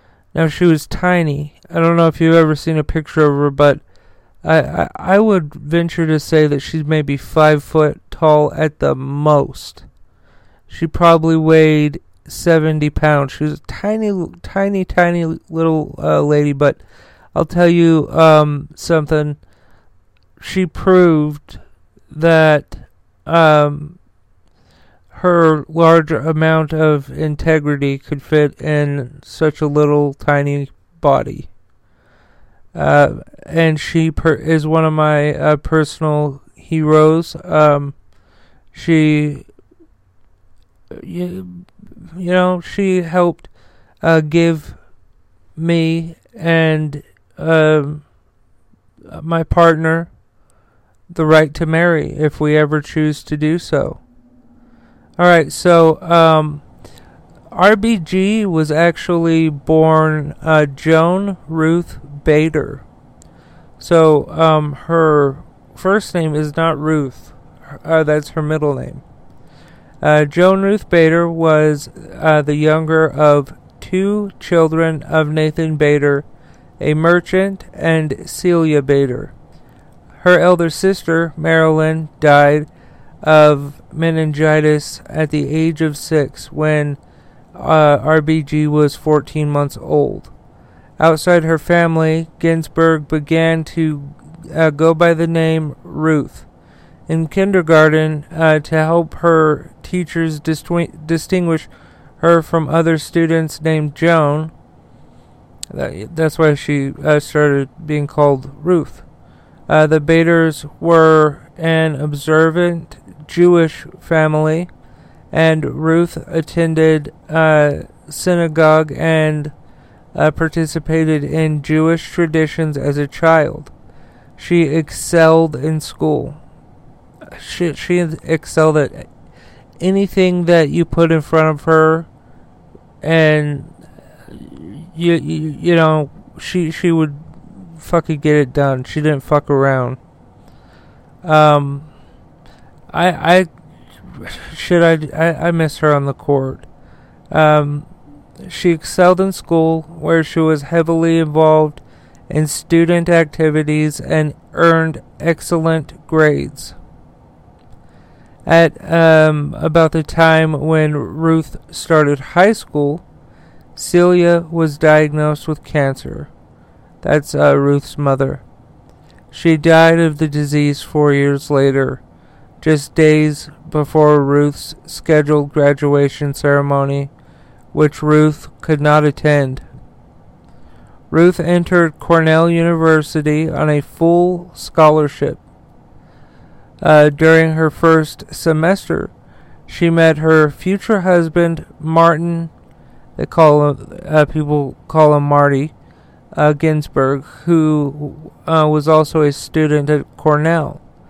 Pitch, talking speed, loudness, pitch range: 155 Hz, 110 wpm, -14 LUFS, 150-165 Hz